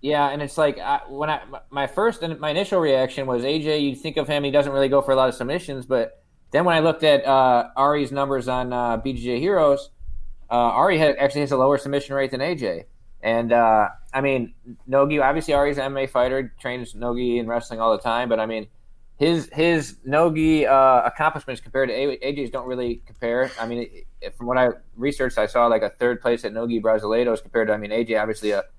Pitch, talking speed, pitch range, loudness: 135 Hz, 225 wpm, 120-140 Hz, -21 LUFS